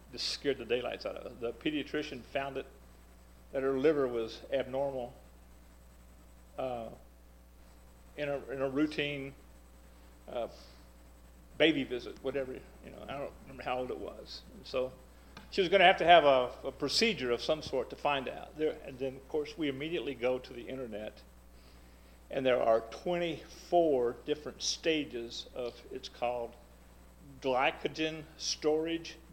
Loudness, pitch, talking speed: -33 LUFS, 125 Hz, 155 wpm